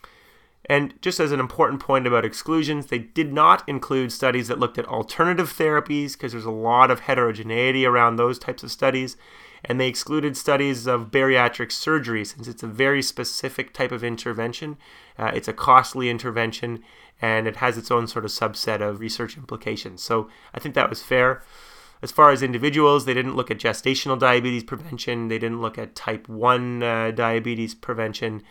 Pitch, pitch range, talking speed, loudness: 125 Hz, 115-135 Hz, 180 wpm, -22 LUFS